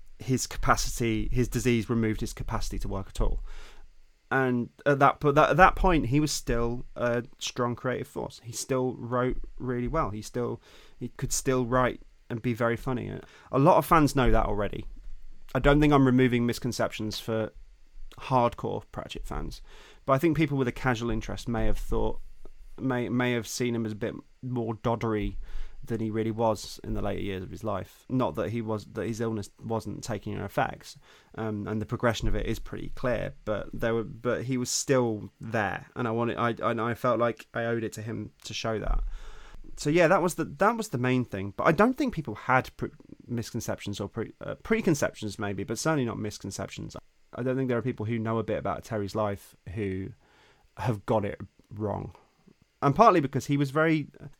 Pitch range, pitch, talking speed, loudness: 110-130 Hz, 120 Hz, 200 wpm, -28 LUFS